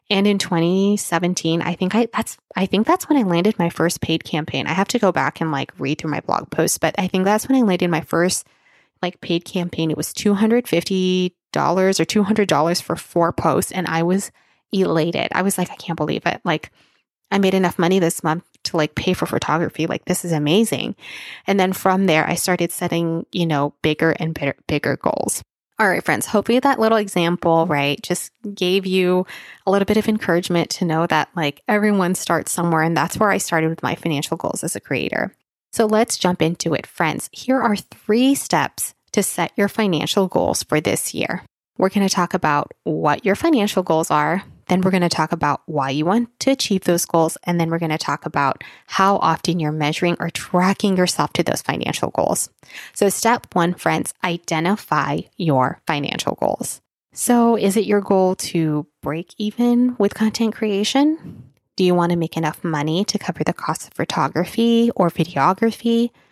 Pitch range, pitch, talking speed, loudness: 165-205 Hz, 180 Hz, 205 wpm, -19 LUFS